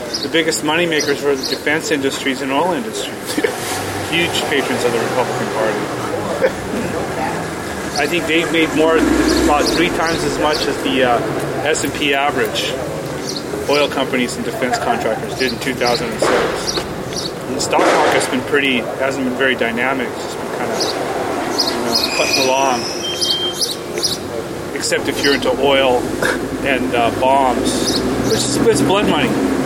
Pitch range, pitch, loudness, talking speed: 130-160 Hz, 140 Hz, -17 LUFS, 145 wpm